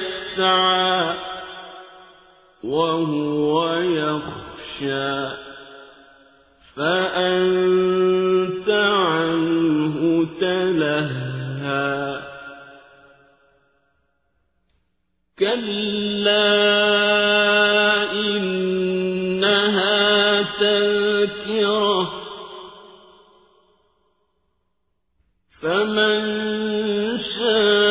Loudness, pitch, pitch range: -19 LUFS, 185 Hz, 150-205 Hz